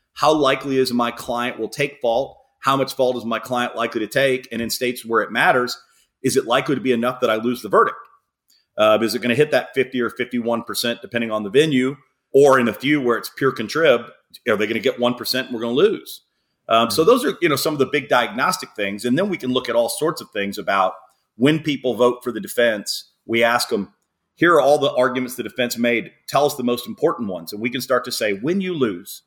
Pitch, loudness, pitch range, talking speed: 125 Hz, -20 LUFS, 115-130 Hz, 250 wpm